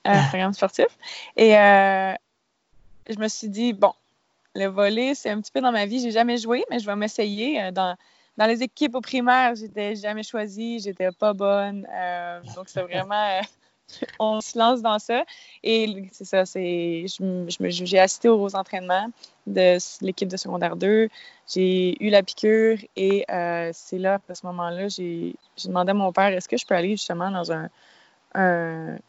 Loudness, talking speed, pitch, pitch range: -23 LUFS, 185 wpm, 200 Hz, 185-220 Hz